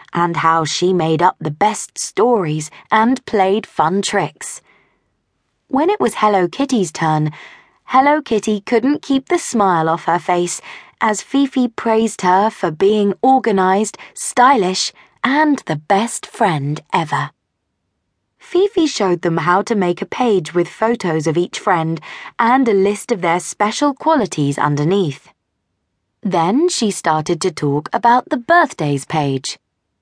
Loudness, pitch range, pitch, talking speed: -16 LUFS, 165-235 Hz, 195 Hz, 140 wpm